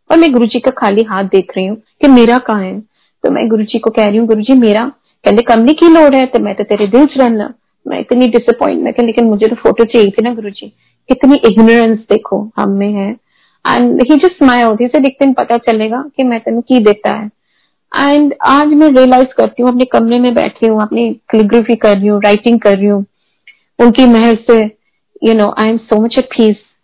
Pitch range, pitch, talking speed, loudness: 215-255 Hz, 235 Hz, 225 wpm, -9 LUFS